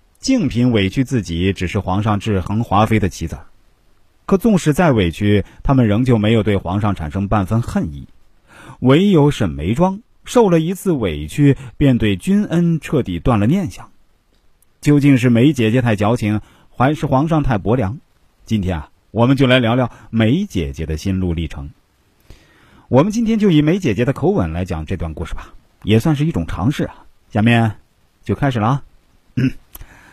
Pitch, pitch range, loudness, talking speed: 110 Hz, 95-140 Hz, -16 LUFS, 250 characters per minute